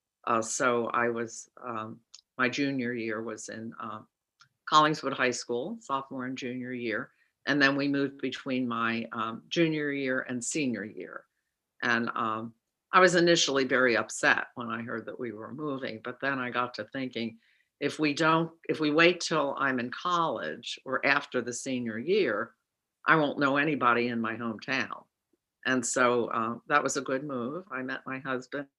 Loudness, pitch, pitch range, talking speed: -29 LUFS, 130 Hz, 120-140 Hz, 175 wpm